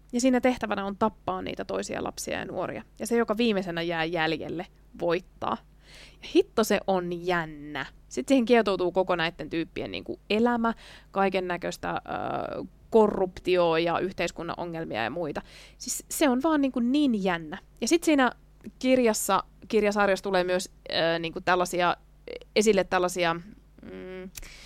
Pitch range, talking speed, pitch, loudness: 175-235 Hz, 140 wpm, 190 Hz, -27 LUFS